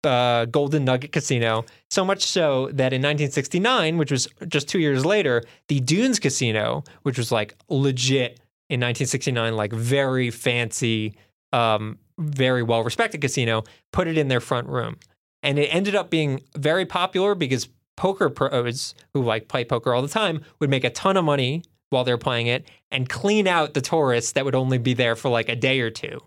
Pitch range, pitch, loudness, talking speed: 120-150 Hz, 130 Hz, -22 LUFS, 185 wpm